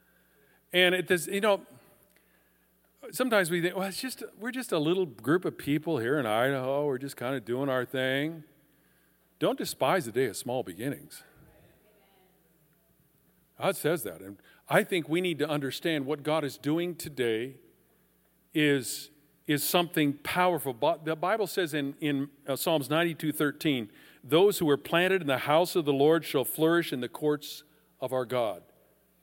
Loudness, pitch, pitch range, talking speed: -29 LUFS, 150 Hz, 140-175 Hz, 165 wpm